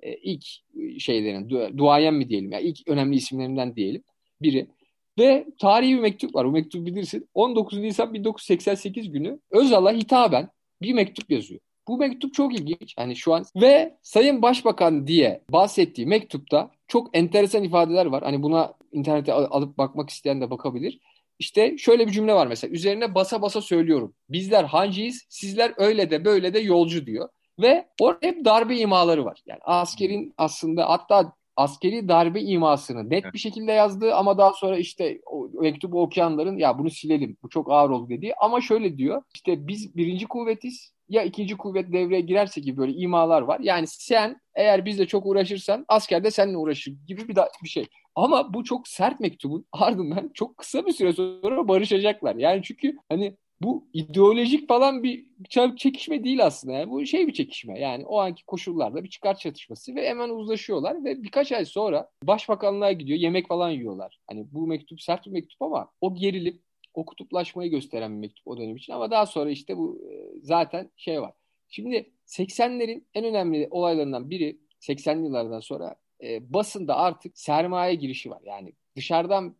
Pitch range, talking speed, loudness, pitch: 160-230 Hz, 170 wpm, -23 LUFS, 195 Hz